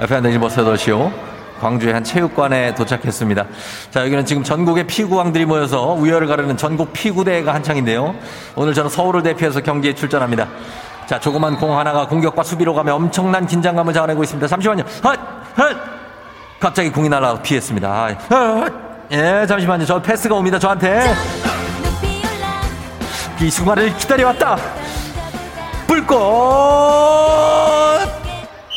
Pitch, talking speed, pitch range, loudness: 155 Hz, 330 characters per minute, 125-190 Hz, -16 LUFS